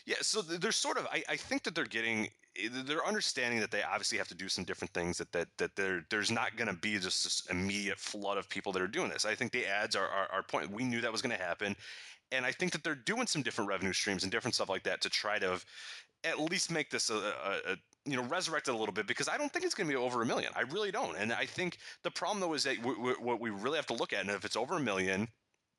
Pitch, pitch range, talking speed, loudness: 125 Hz, 105-170 Hz, 285 wpm, -35 LUFS